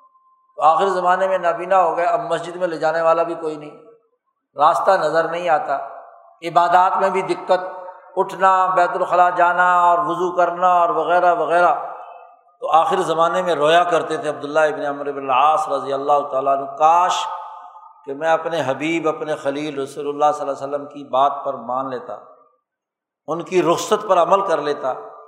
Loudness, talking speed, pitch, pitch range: -18 LUFS, 175 wpm, 170 Hz, 150-180 Hz